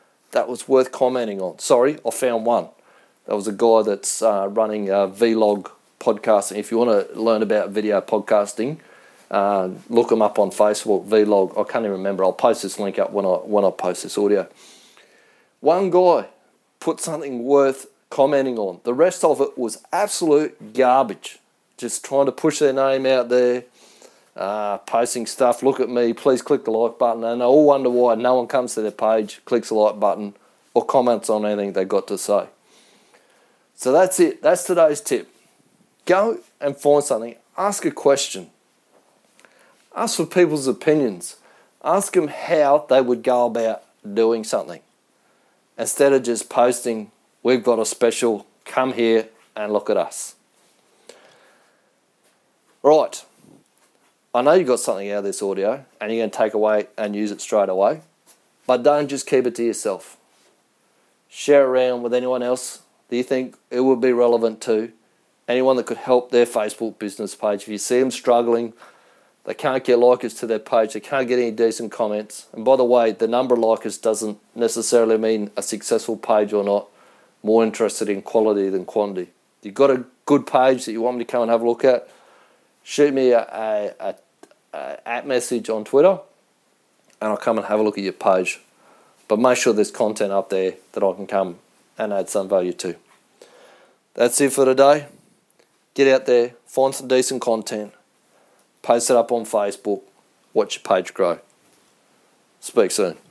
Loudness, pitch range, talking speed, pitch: -20 LUFS, 105-130 Hz, 180 wpm, 120 Hz